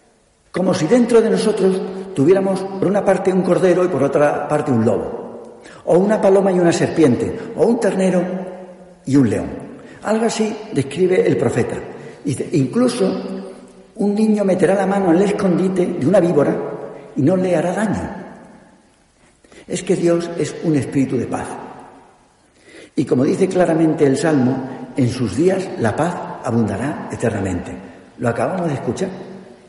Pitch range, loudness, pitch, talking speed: 135-195 Hz, -17 LUFS, 180 Hz, 155 wpm